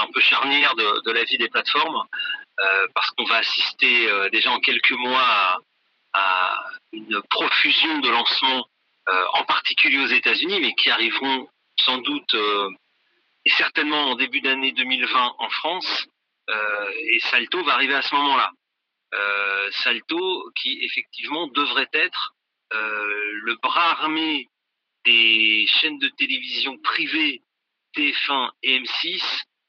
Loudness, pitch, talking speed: -20 LUFS, 145 Hz, 140 wpm